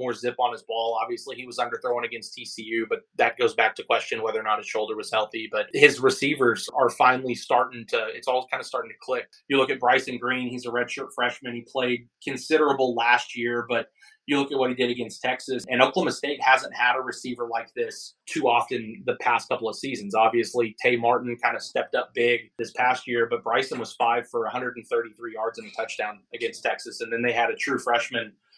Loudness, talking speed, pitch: -25 LUFS, 225 wpm, 125 Hz